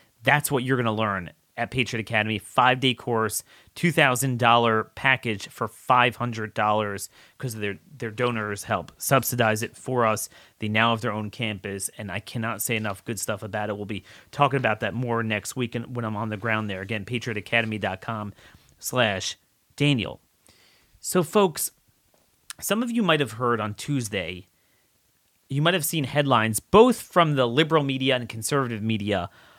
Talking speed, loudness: 170 wpm, -24 LUFS